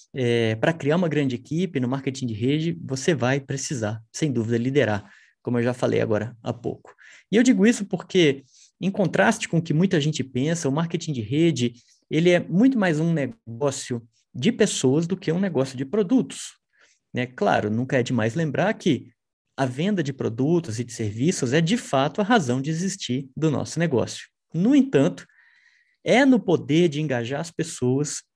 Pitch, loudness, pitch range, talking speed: 150 Hz, -23 LUFS, 125-180 Hz, 185 wpm